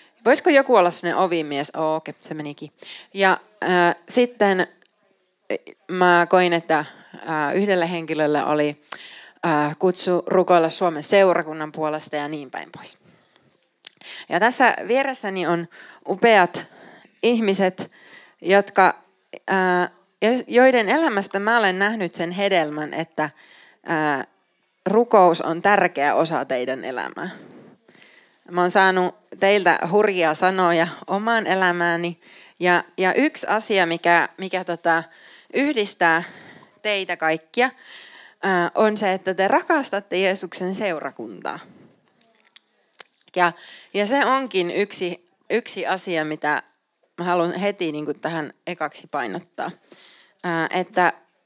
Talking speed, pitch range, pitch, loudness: 110 wpm, 165-200 Hz, 180 Hz, -21 LUFS